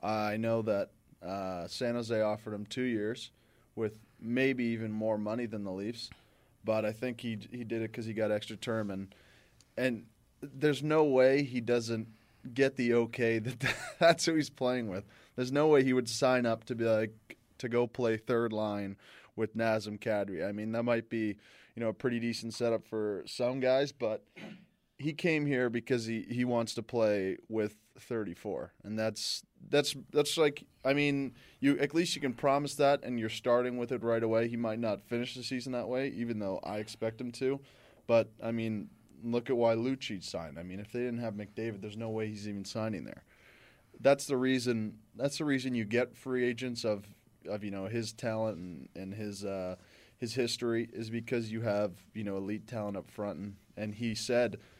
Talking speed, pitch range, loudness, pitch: 200 wpm, 110-125 Hz, -33 LUFS, 115 Hz